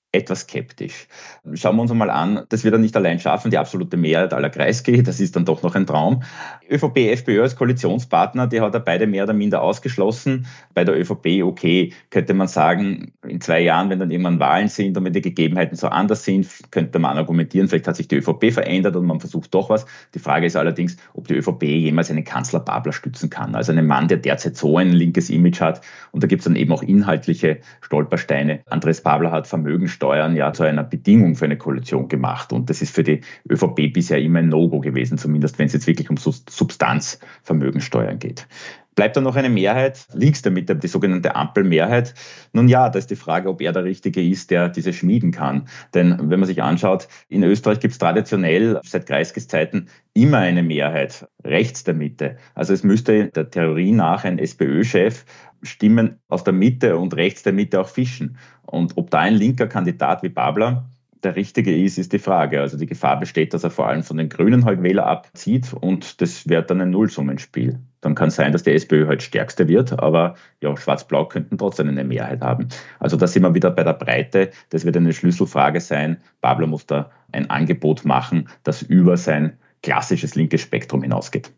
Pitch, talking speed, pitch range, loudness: 85 Hz, 205 wpm, 75-100 Hz, -19 LUFS